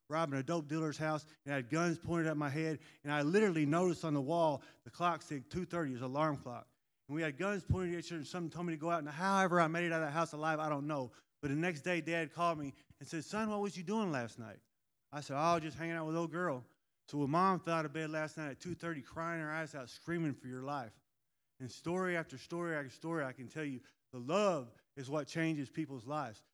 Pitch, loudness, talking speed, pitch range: 155 Hz, -38 LUFS, 265 wpm, 140-170 Hz